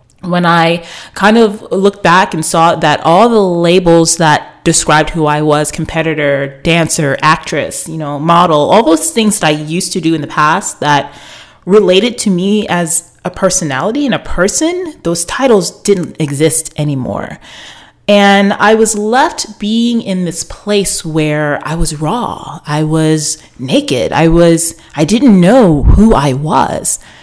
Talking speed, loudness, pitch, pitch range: 160 wpm, -10 LUFS, 170 Hz, 155-200 Hz